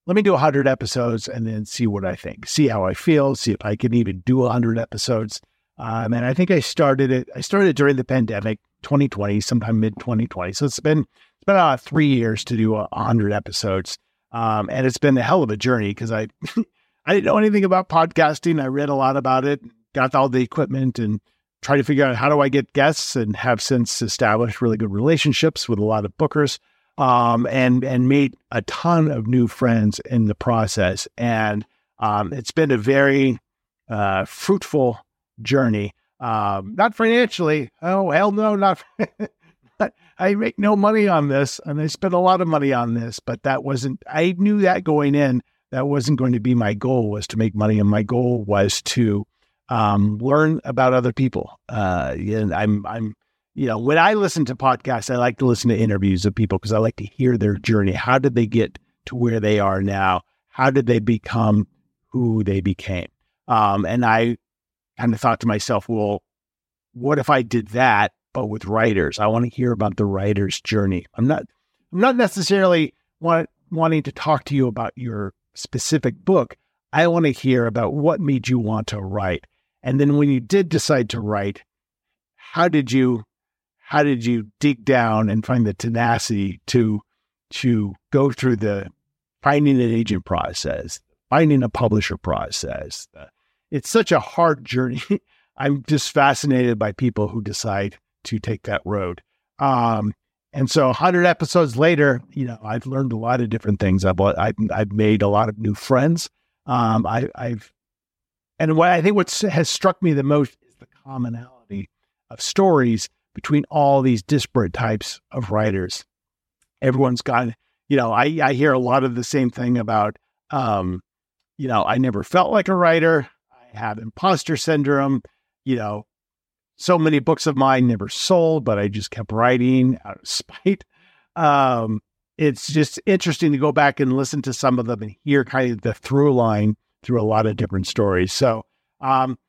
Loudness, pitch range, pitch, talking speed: -20 LUFS, 110-145 Hz, 125 Hz, 190 wpm